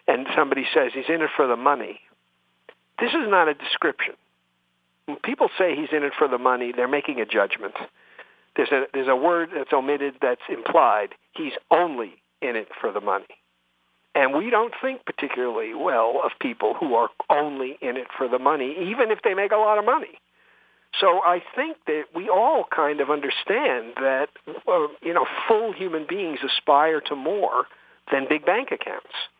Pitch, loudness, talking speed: 155 Hz, -23 LUFS, 180 wpm